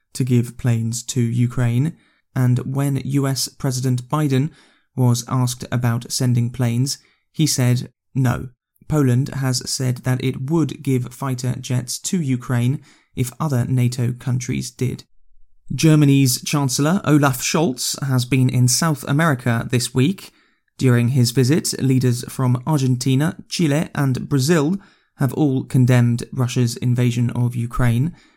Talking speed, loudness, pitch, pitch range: 130 wpm, -19 LUFS, 130 Hz, 125-140 Hz